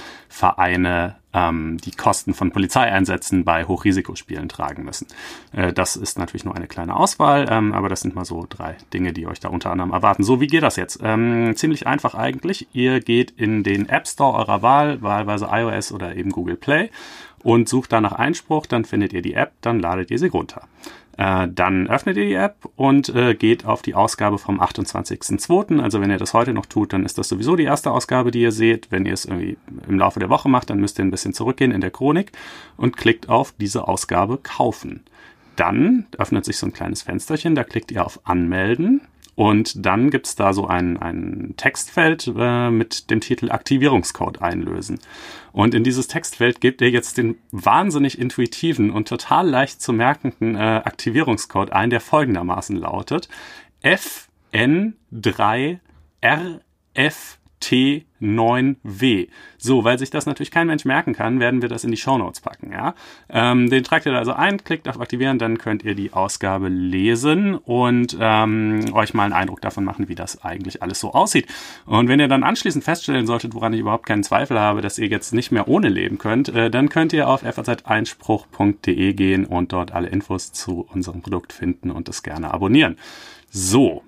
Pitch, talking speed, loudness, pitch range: 115 Hz, 185 wpm, -19 LUFS, 95-130 Hz